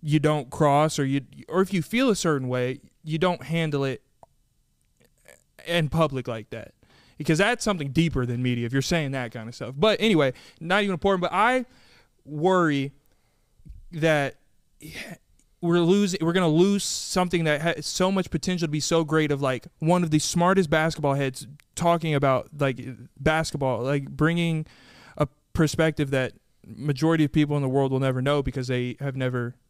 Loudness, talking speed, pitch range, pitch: -24 LUFS, 175 wpm, 135-170 Hz, 150 Hz